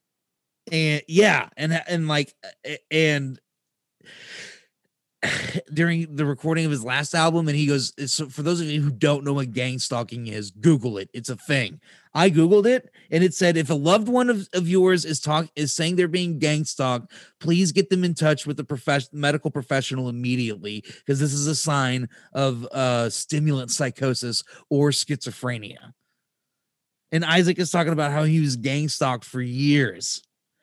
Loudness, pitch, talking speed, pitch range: -23 LUFS, 150 Hz, 170 wpm, 130-165 Hz